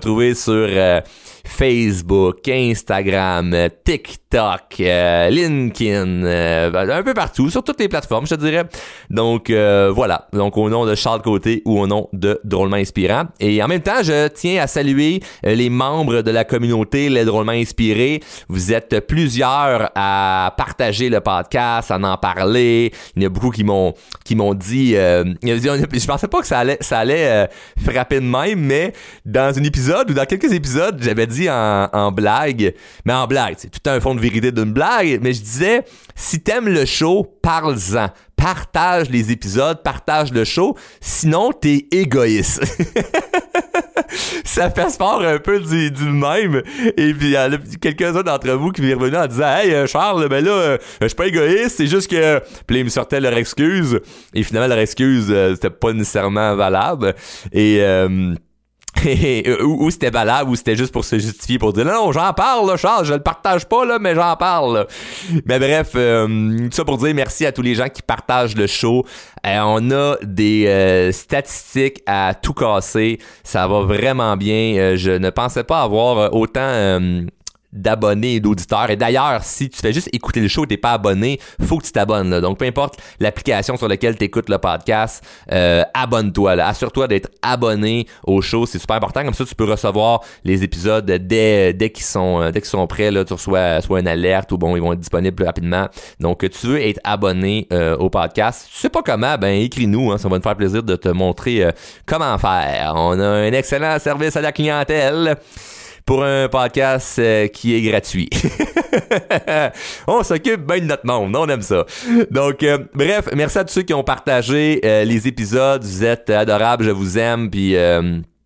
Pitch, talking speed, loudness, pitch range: 115 Hz, 190 wpm, -17 LUFS, 100-140 Hz